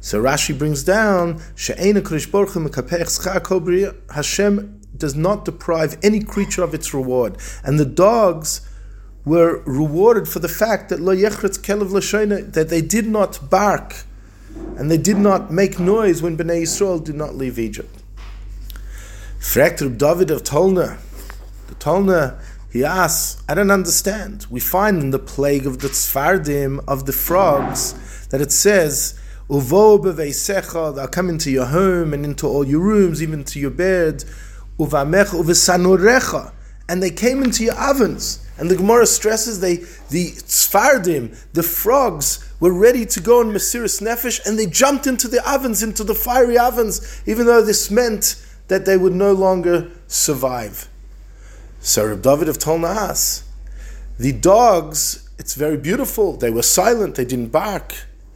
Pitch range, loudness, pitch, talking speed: 135-200 Hz, -17 LUFS, 170 Hz, 140 wpm